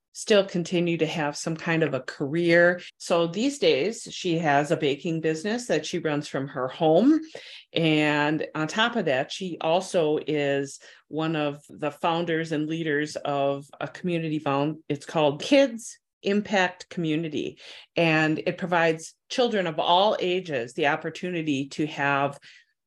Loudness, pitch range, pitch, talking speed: -25 LUFS, 150-180 Hz, 160 Hz, 150 wpm